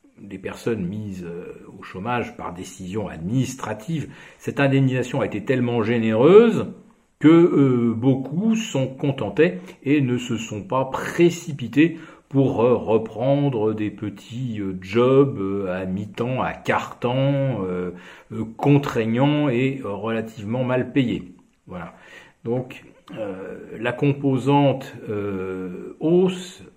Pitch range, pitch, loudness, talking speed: 110-140 Hz, 125 Hz, -21 LUFS, 120 wpm